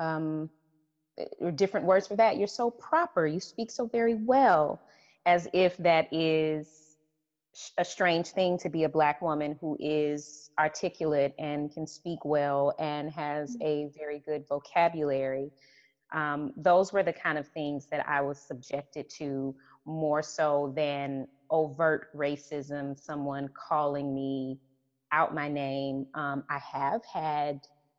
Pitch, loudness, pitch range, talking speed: 150 Hz, -30 LUFS, 145-165 Hz, 140 wpm